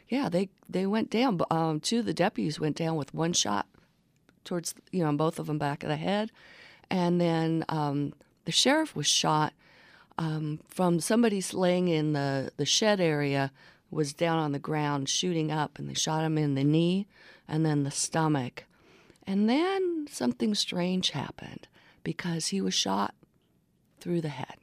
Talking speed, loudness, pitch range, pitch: 175 wpm, -28 LUFS, 150-190 Hz, 165 Hz